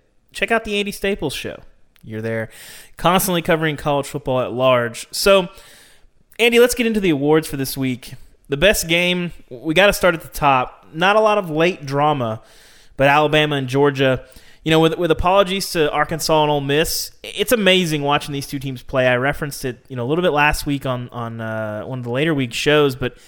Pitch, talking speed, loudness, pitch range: 150 Hz, 210 wpm, -18 LUFS, 130-175 Hz